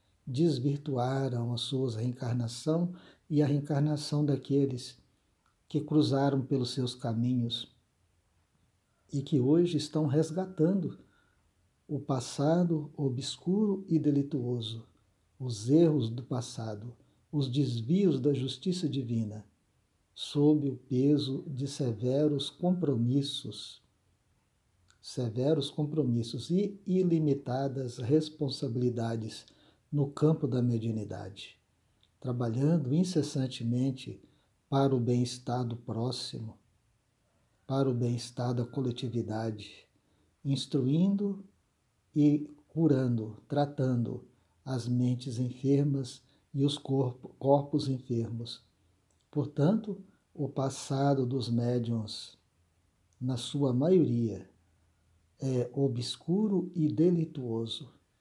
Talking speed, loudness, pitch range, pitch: 85 wpm, -31 LUFS, 115-145 Hz, 130 Hz